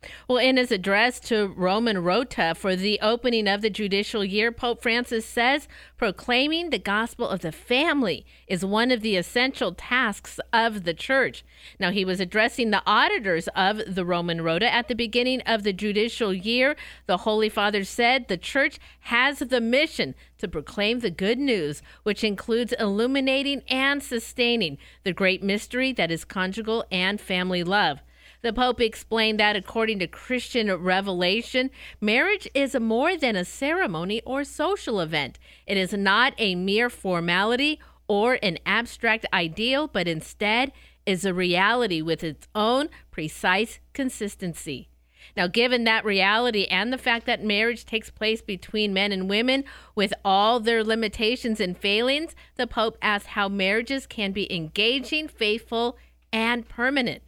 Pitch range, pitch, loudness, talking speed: 195-245 Hz, 220 Hz, -24 LUFS, 155 wpm